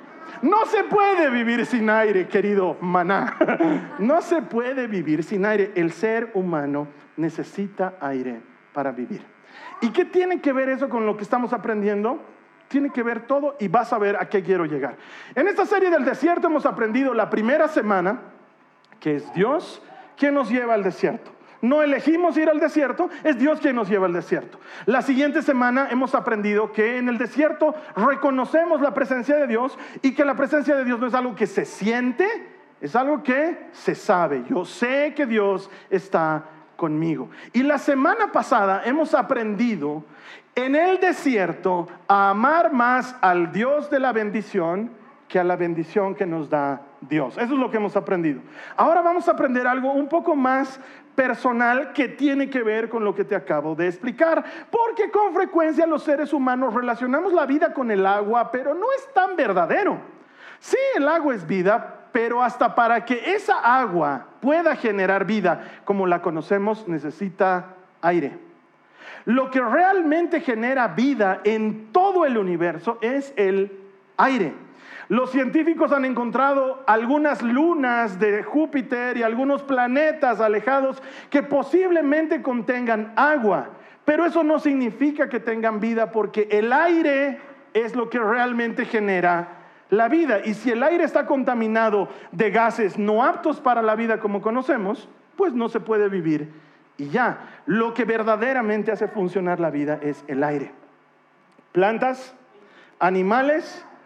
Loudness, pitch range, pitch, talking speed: -21 LUFS, 200-290 Hz, 245 Hz, 160 wpm